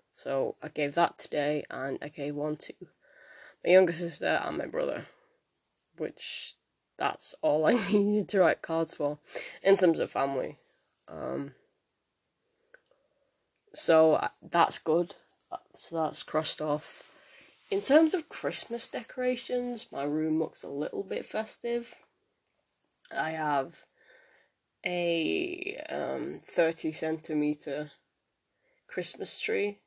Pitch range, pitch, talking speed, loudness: 155-235 Hz, 170 Hz, 115 wpm, -30 LUFS